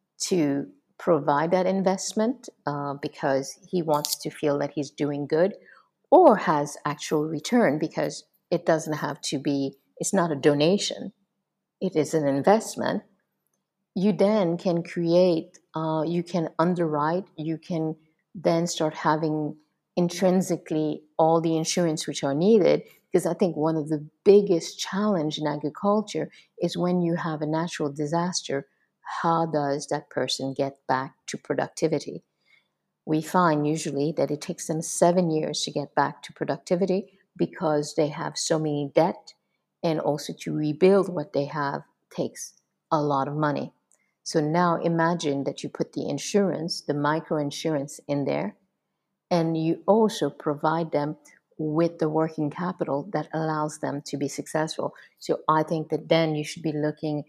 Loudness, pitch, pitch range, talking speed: -25 LUFS, 160 Hz, 150-175 Hz, 155 wpm